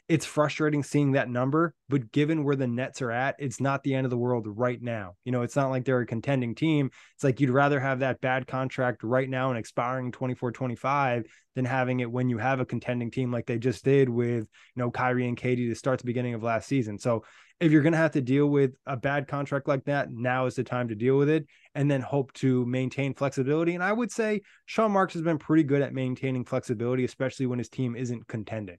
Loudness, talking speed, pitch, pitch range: -27 LUFS, 245 wpm, 130 Hz, 125-140 Hz